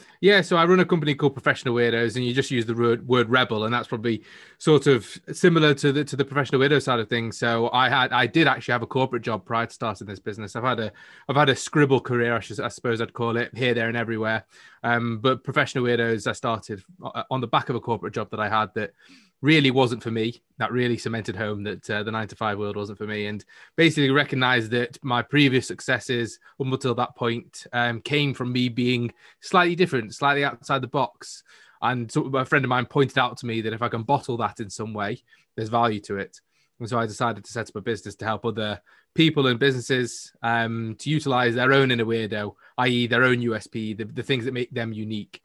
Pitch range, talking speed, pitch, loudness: 115-135 Hz, 235 wpm, 120 Hz, -23 LUFS